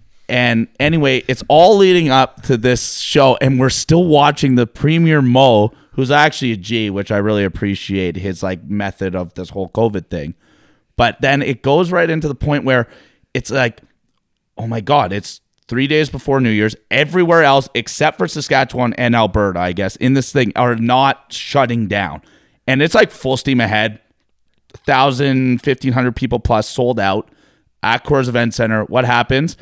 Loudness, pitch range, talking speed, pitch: -15 LUFS, 105-140 Hz, 175 wpm, 125 Hz